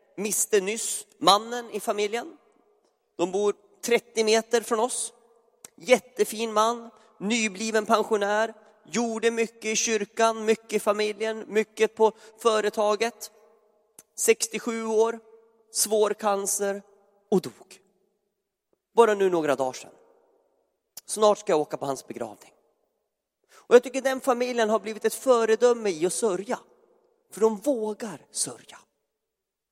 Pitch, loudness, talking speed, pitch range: 220 Hz, -25 LUFS, 120 wpm, 210-230 Hz